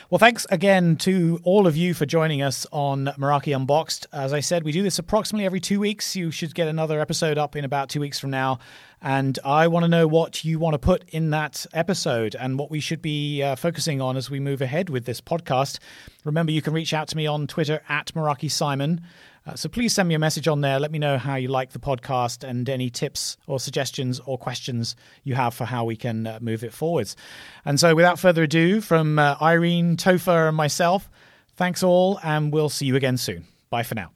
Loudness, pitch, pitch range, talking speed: -23 LUFS, 150 Hz, 135-170 Hz, 230 wpm